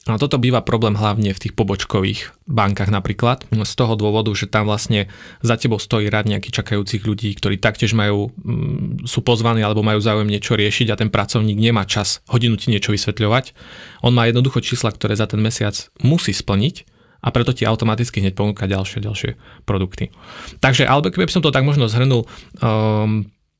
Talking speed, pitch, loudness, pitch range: 180 wpm, 110 Hz, -18 LUFS, 105-120 Hz